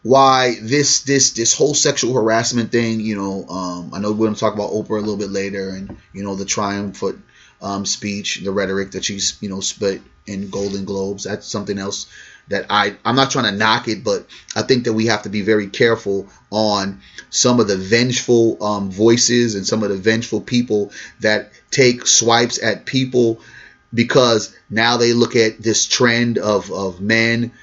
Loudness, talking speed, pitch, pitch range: -17 LUFS, 195 wpm, 110 Hz, 100-115 Hz